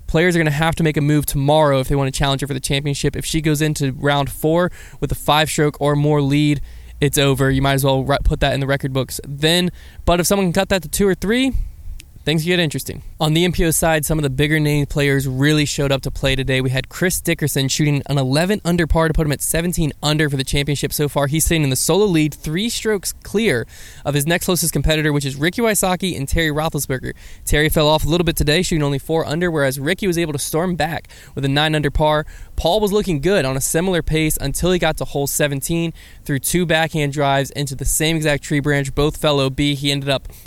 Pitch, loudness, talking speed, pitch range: 150 Hz, -18 LUFS, 250 wpm, 140-165 Hz